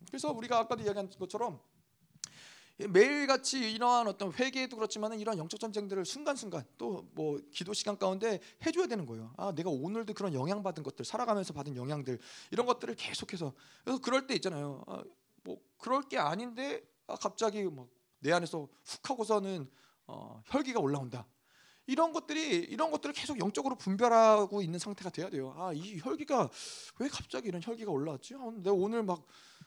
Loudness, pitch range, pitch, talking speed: -34 LUFS, 165-245 Hz, 205 Hz, 380 characters per minute